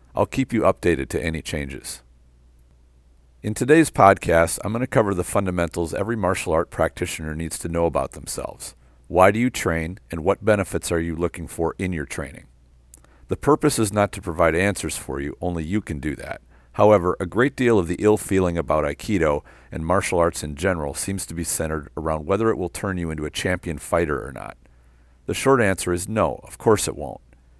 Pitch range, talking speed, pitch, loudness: 75-100 Hz, 200 wpm, 85 Hz, -22 LUFS